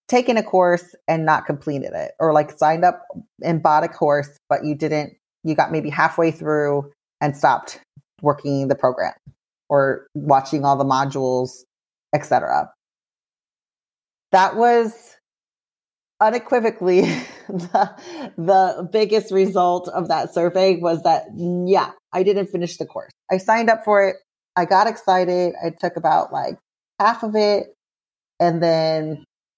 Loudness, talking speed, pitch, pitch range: -19 LUFS, 140 wpm, 175 Hz, 150-195 Hz